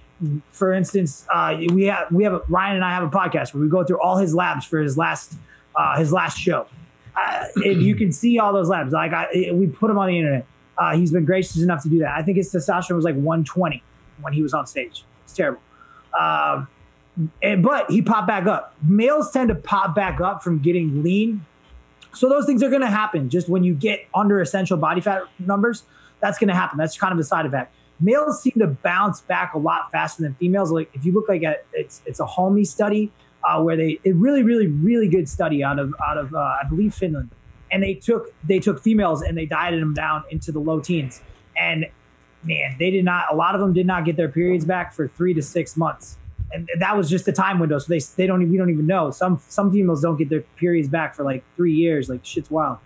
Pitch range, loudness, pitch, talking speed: 160-195 Hz, -21 LUFS, 180 Hz, 240 wpm